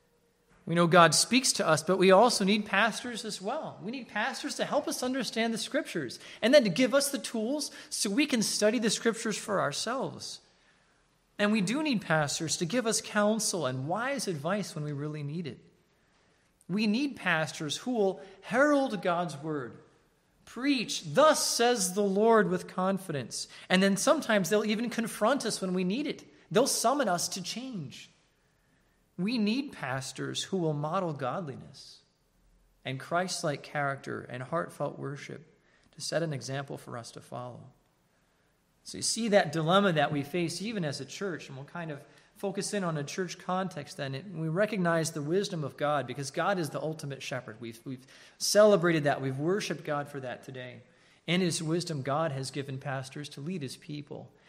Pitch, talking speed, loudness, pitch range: 180 Hz, 180 wpm, -29 LUFS, 145-215 Hz